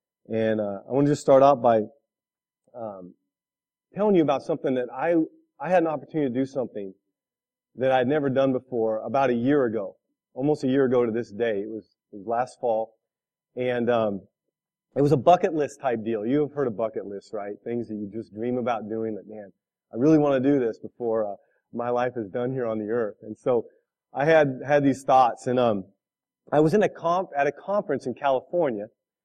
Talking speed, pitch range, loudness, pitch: 215 wpm, 110-145 Hz, -24 LUFS, 125 Hz